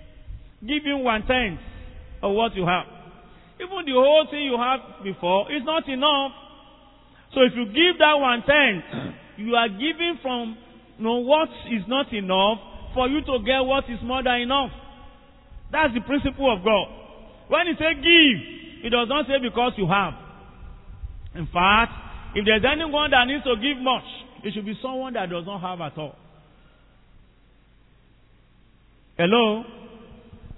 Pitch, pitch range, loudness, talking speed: 245 Hz, 205-285 Hz, -21 LUFS, 160 wpm